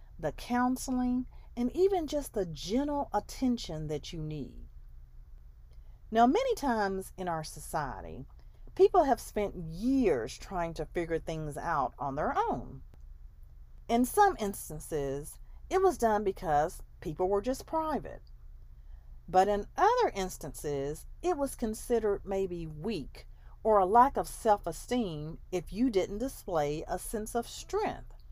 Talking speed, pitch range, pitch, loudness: 135 wpm, 150-245 Hz, 190 Hz, -31 LUFS